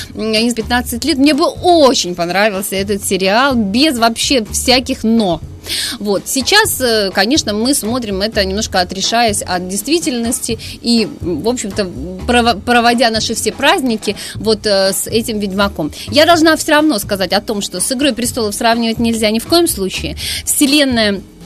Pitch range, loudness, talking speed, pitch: 205-265 Hz, -13 LUFS, 150 wpm, 230 Hz